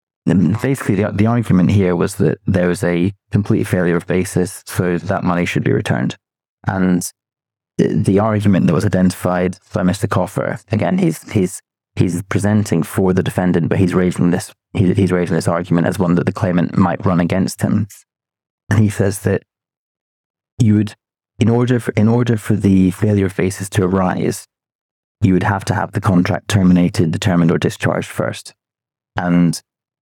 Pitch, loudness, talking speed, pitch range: 95 Hz, -16 LUFS, 170 wpm, 90-105 Hz